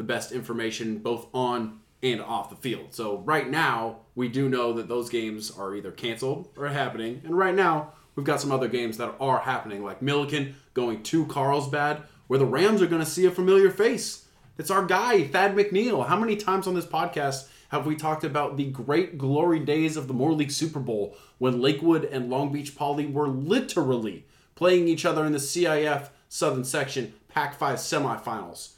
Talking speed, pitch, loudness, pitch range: 195 wpm, 140 Hz, -26 LUFS, 125-160 Hz